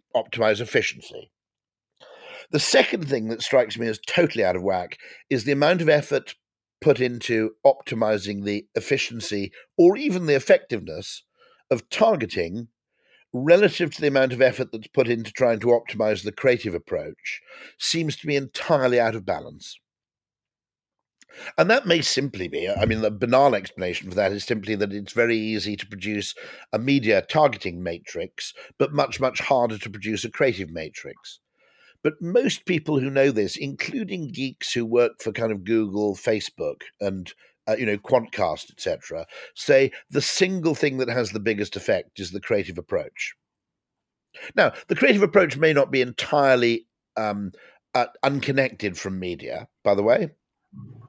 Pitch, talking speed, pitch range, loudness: 120 Hz, 155 wpm, 105-140 Hz, -23 LUFS